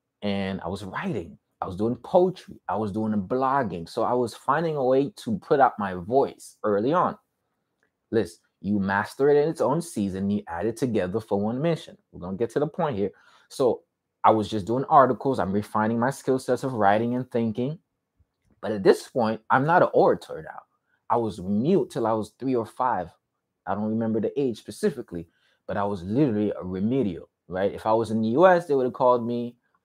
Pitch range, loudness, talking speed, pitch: 105-135 Hz, -25 LUFS, 210 wpm, 115 Hz